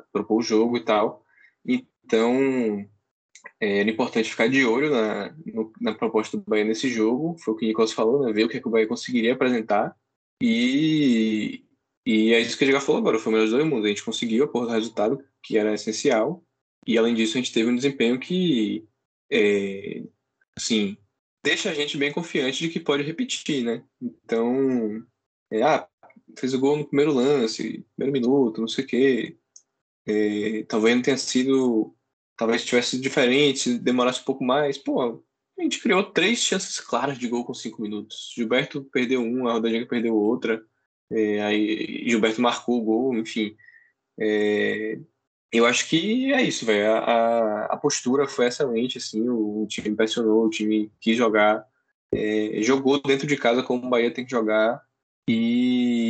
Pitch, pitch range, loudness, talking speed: 120 Hz, 110-135 Hz, -23 LUFS, 180 wpm